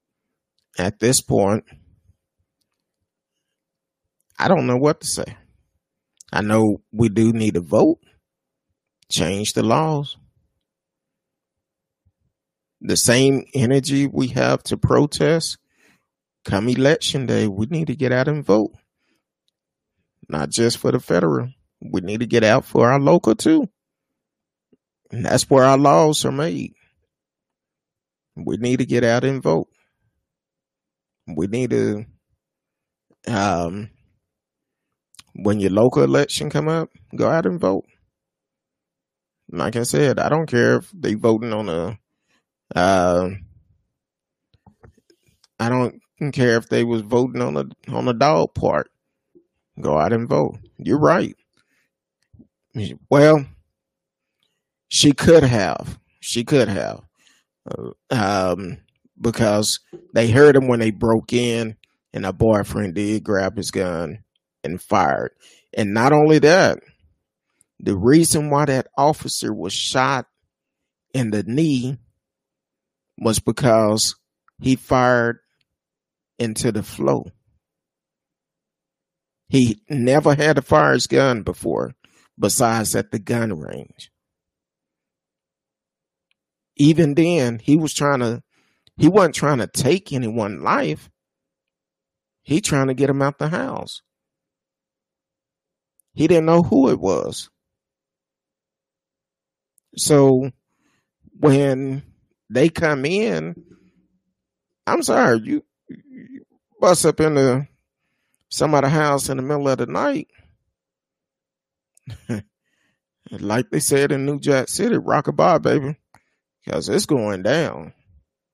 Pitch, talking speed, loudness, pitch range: 125 Hz, 115 wpm, -18 LUFS, 110-145 Hz